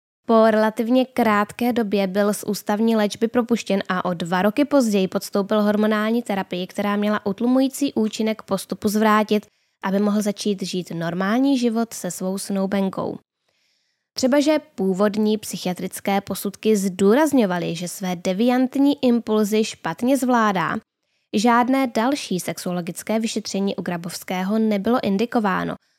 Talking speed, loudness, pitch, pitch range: 120 wpm, -21 LUFS, 210 Hz, 195-235 Hz